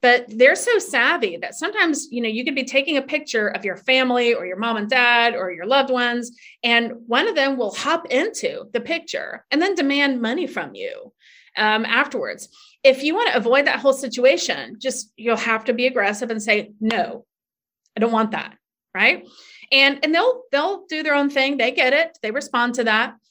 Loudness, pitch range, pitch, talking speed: -19 LUFS, 230-290 Hz, 255 Hz, 205 wpm